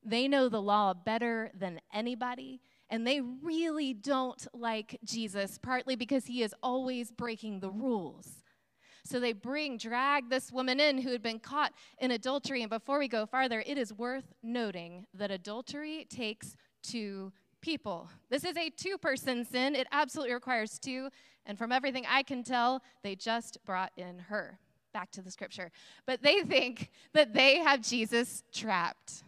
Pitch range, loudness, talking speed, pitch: 220-265 Hz, -33 LUFS, 165 wpm, 245 Hz